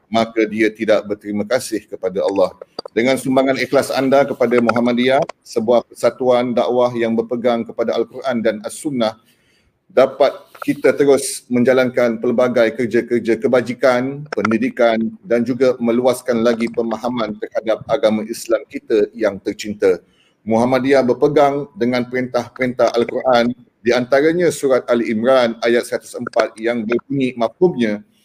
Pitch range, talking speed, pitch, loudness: 115-130 Hz, 120 wpm, 120 Hz, -17 LUFS